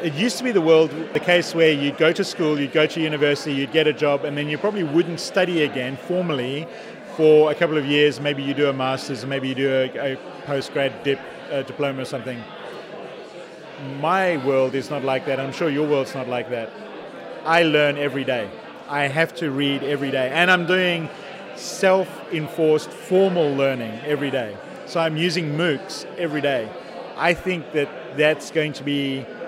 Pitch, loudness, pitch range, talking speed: 150 Hz, -21 LUFS, 140-165 Hz, 195 wpm